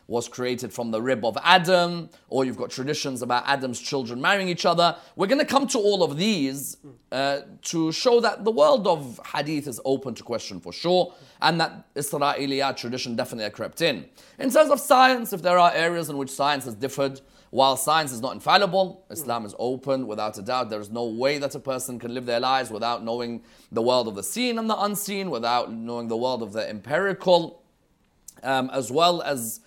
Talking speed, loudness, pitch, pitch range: 205 wpm, -24 LUFS, 140 Hz, 120-175 Hz